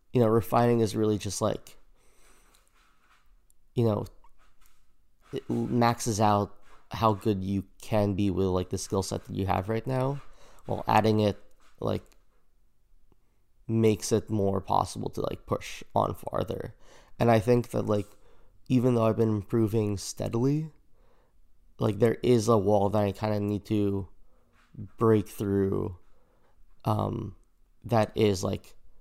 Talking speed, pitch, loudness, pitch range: 140 wpm, 110 Hz, -28 LUFS, 100-115 Hz